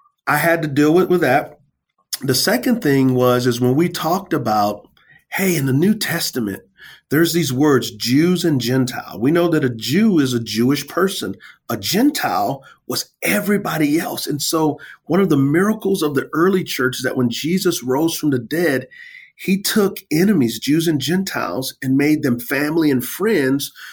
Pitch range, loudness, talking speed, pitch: 130-185 Hz, -18 LUFS, 180 wpm, 155 Hz